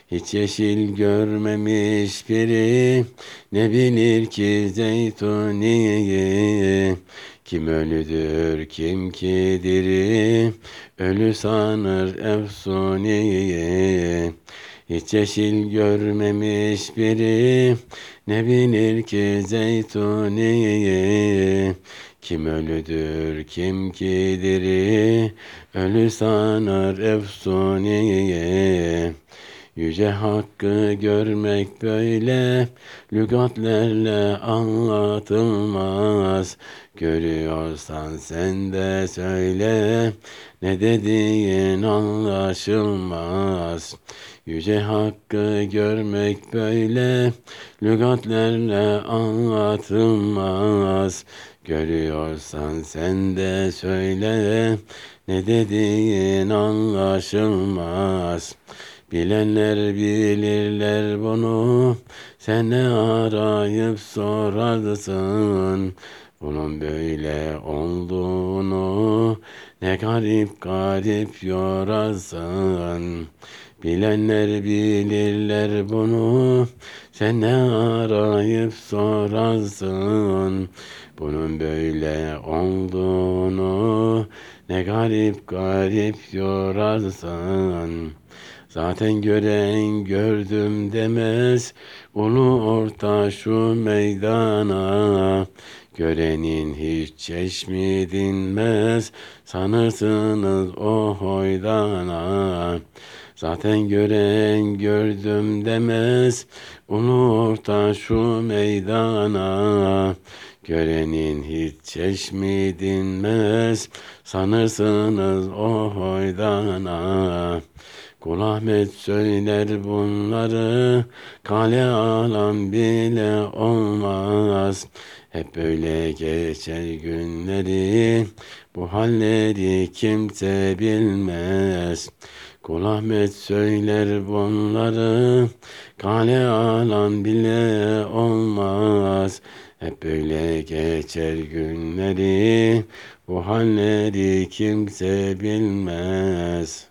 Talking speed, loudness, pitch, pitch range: 60 wpm, -21 LUFS, 105 Hz, 95-110 Hz